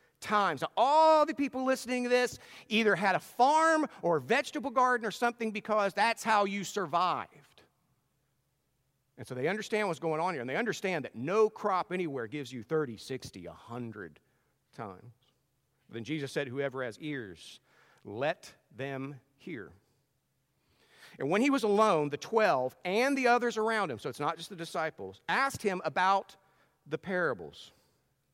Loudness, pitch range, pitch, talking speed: -30 LUFS, 135-220 Hz, 175 Hz, 160 wpm